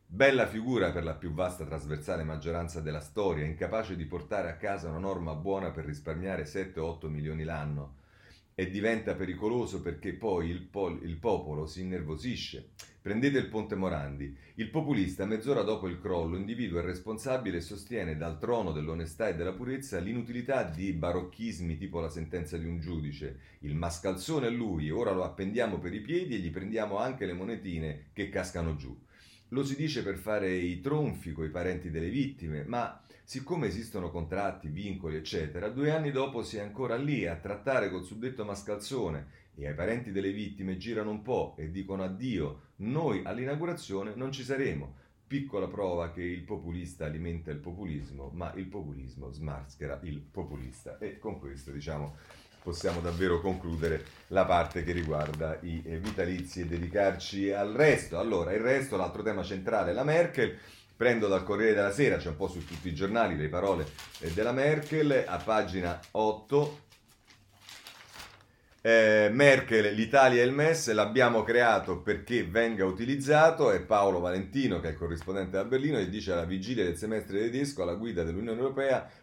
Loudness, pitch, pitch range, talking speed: -31 LUFS, 95 Hz, 85-110 Hz, 165 wpm